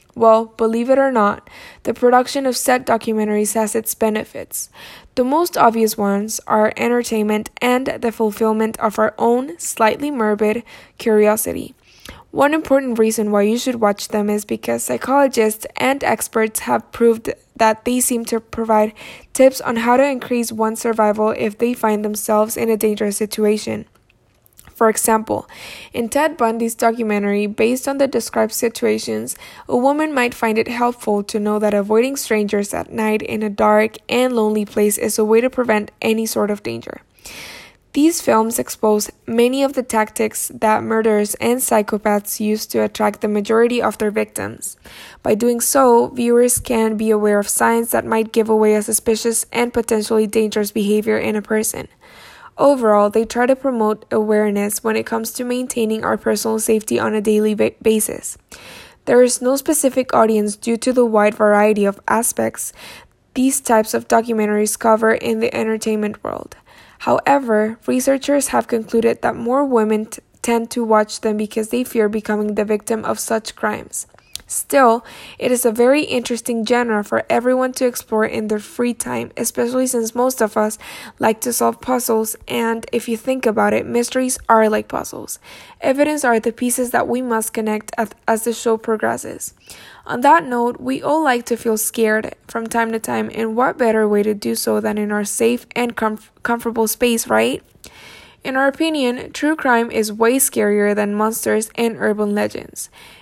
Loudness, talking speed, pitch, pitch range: -17 LUFS, 170 wpm, 225 Hz, 215-245 Hz